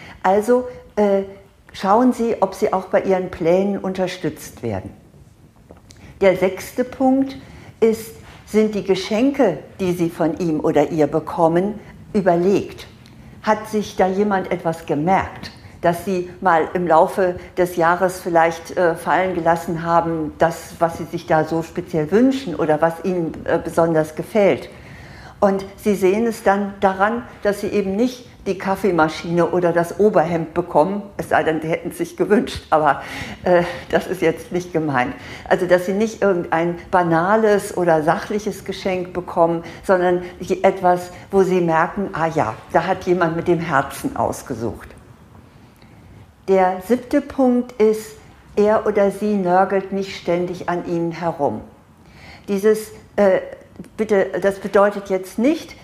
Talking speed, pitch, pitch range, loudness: 145 wpm, 185 Hz, 165-200 Hz, -19 LUFS